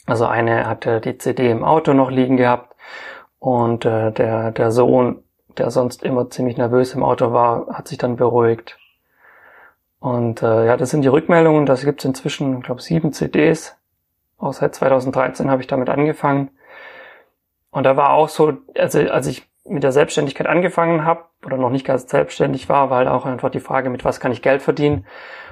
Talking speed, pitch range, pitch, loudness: 185 wpm, 125-145 Hz, 130 Hz, -17 LUFS